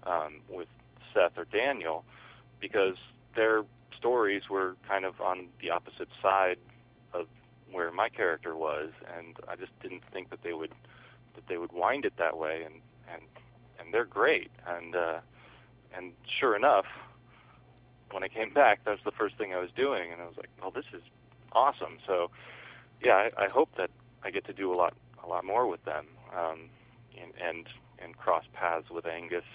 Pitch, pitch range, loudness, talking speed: 95 Hz, 85-110 Hz, -31 LUFS, 185 wpm